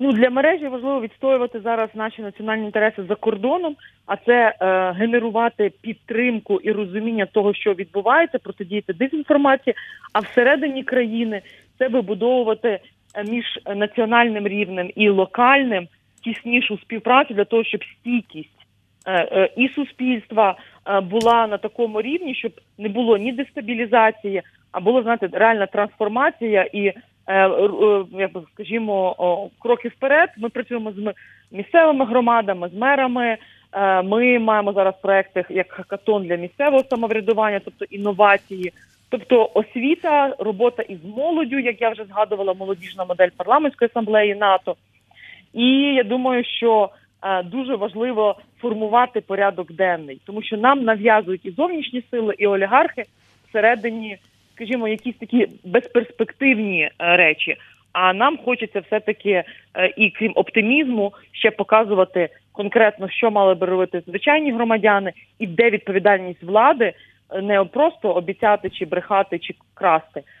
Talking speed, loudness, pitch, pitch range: 125 wpm, -19 LUFS, 215 Hz, 195-245 Hz